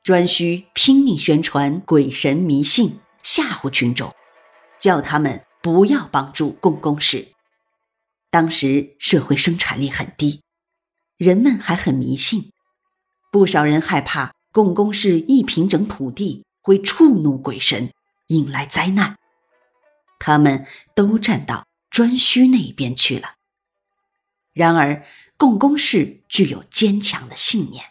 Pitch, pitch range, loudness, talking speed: 180 Hz, 145-225 Hz, -17 LUFS, 180 characters per minute